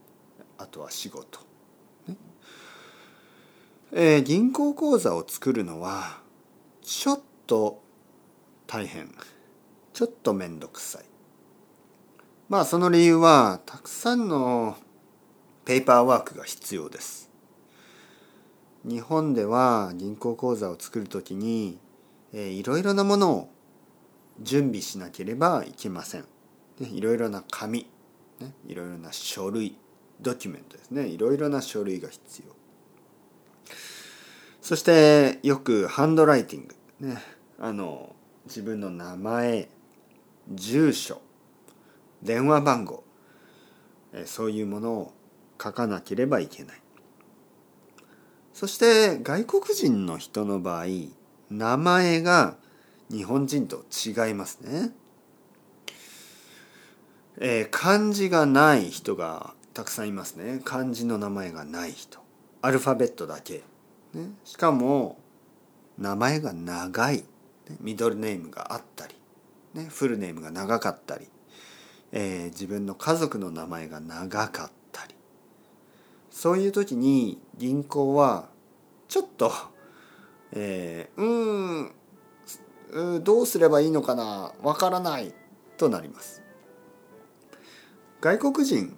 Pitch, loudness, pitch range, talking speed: 130 Hz, -25 LUFS, 105-170 Hz, 215 characters per minute